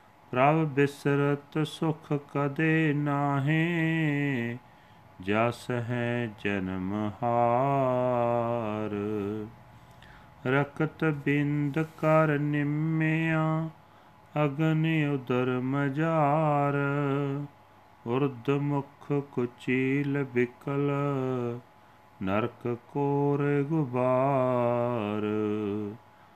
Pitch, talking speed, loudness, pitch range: 140 Hz, 50 wpm, -28 LUFS, 120-145 Hz